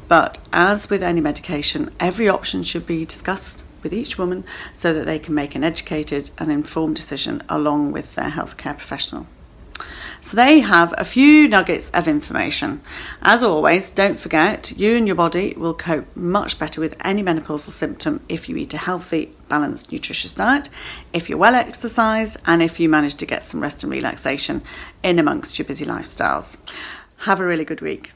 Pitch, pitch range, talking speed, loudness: 170 Hz, 155-205 Hz, 180 wpm, -19 LUFS